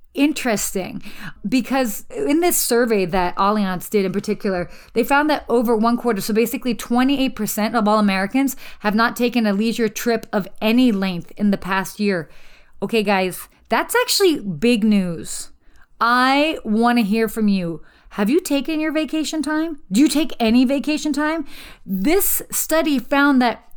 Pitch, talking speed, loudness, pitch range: 235 Hz, 160 wpm, -19 LUFS, 205-280 Hz